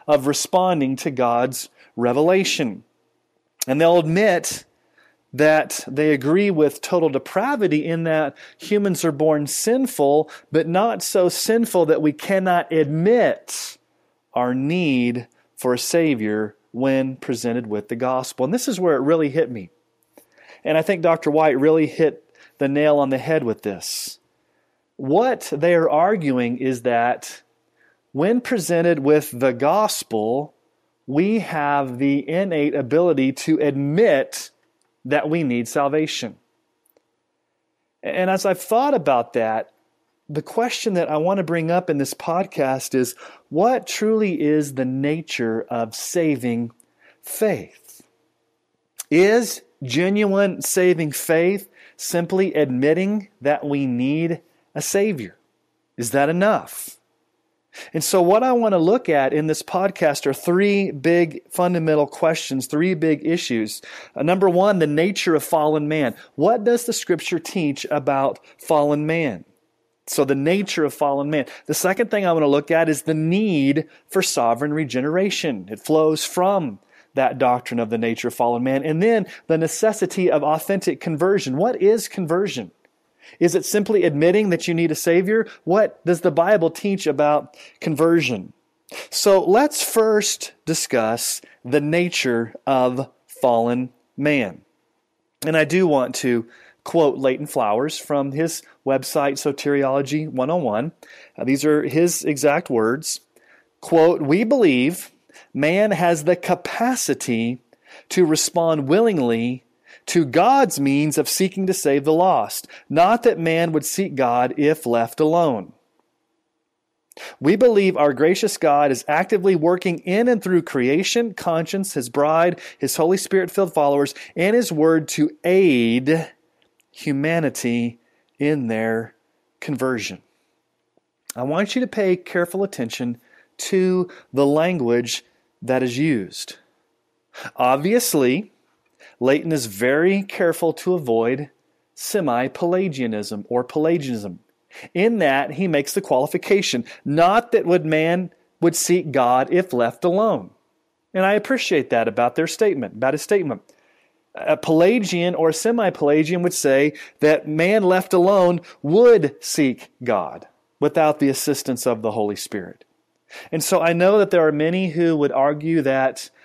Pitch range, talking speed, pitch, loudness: 140-185 Hz, 135 wpm, 160 Hz, -20 LUFS